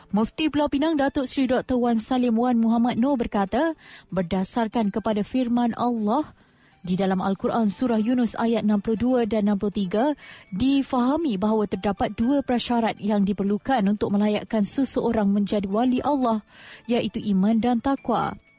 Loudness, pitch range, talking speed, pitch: -23 LUFS, 210-250 Hz, 135 wpm, 230 Hz